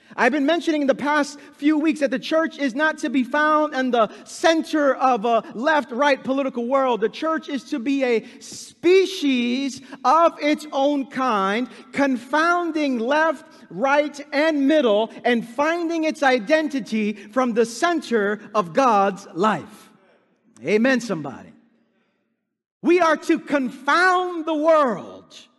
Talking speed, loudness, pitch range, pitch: 140 wpm, -21 LUFS, 245-310 Hz, 280 Hz